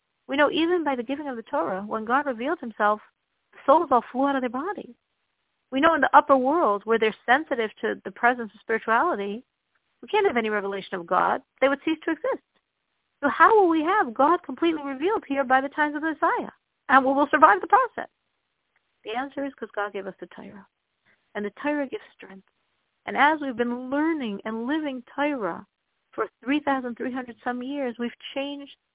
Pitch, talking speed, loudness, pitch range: 270 Hz, 205 wpm, -24 LUFS, 230-300 Hz